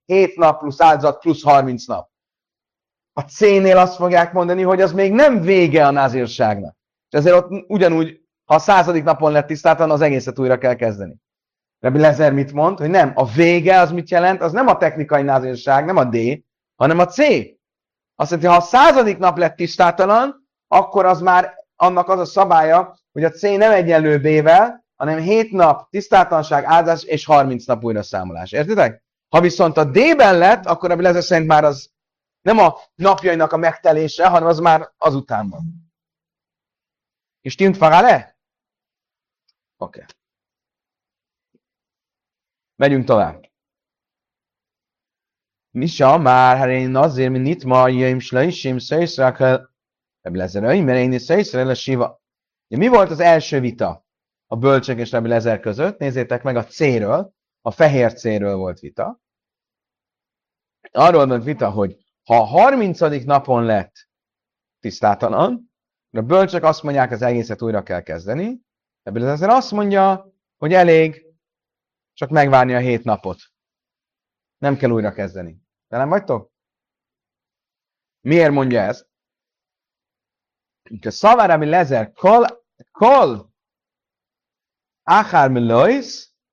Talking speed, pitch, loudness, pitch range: 140 wpm, 155 Hz, -15 LUFS, 130-180 Hz